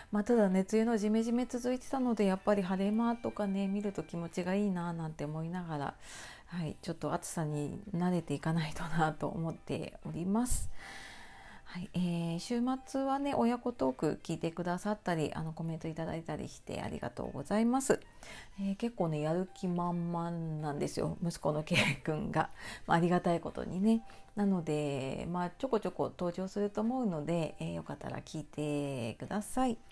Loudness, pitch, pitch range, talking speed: -35 LUFS, 175 Hz, 160-210 Hz, 375 characters per minute